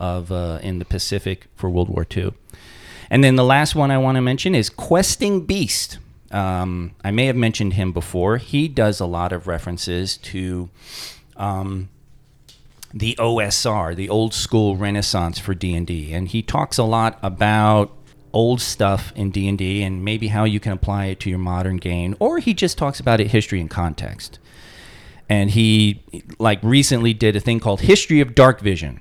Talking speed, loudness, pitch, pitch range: 180 wpm, -19 LUFS, 105 Hz, 95-115 Hz